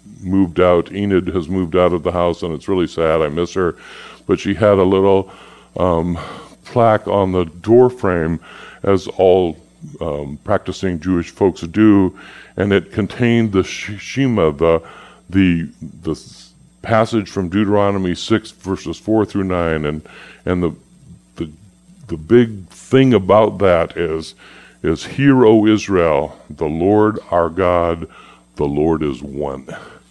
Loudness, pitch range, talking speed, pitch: -16 LUFS, 85-105 Hz, 145 wpm, 95 Hz